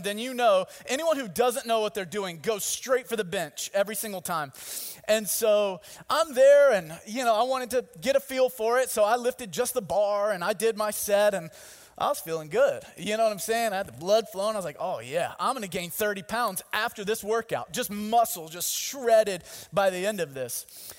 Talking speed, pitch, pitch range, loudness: 235 wpm, 215 Hz, 200-245 Hz, -27 LUFS